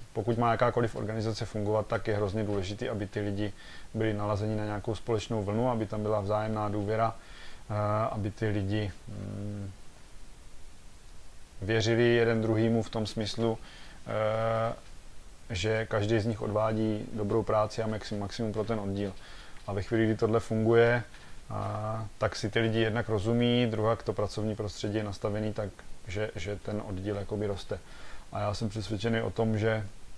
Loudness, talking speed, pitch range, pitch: -31 LUFS, 150 wpm, 105-115 Hz, 110 Hz